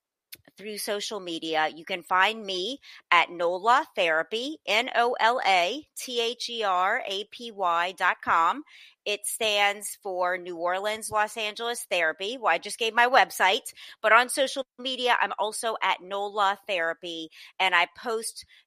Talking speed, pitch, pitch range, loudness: 125 wpm, 205 Hz, 180-235 Hz, -26 LUFS